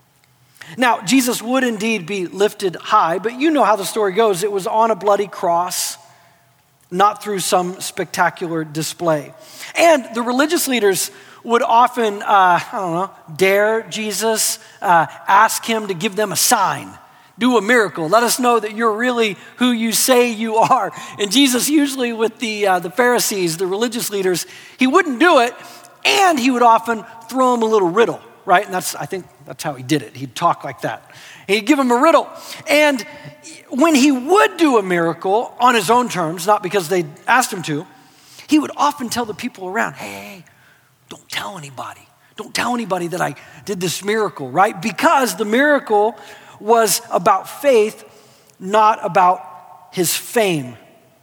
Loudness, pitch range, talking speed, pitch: -17 LUFS, 180-240 Hz, 175 wpm, 215 Hz